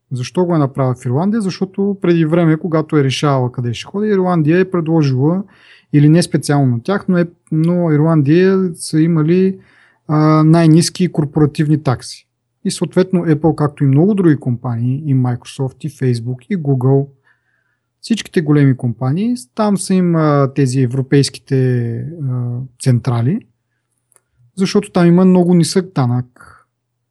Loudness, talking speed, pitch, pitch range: -14 LUFS, 130 wpm, 150 Hz, 130-175 Hz